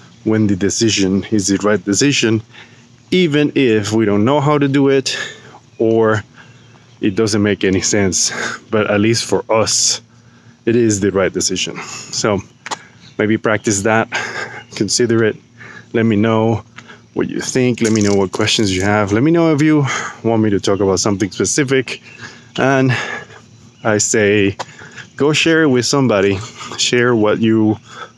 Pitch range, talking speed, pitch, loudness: 105-120 Hz, 160 wpm, 110 Hz, -15 LUFS